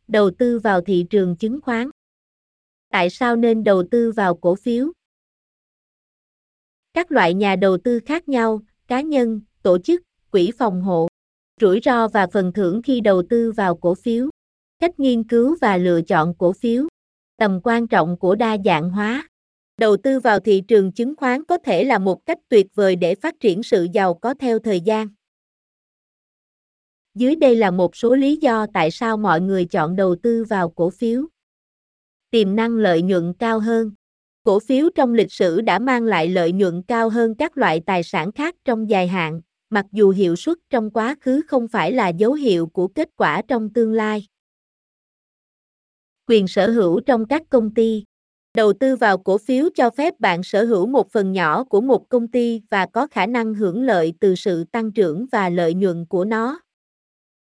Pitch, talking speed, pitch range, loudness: 220 Hz, 185 wpm, 190-245 Hz, -19 LUFS